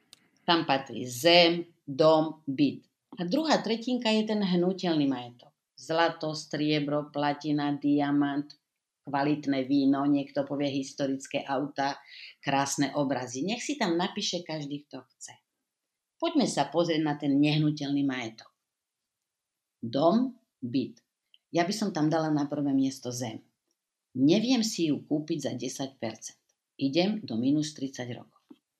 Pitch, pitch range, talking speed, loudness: 150 Hz, 140-170 Hz, 125 wpm, -28 LUFS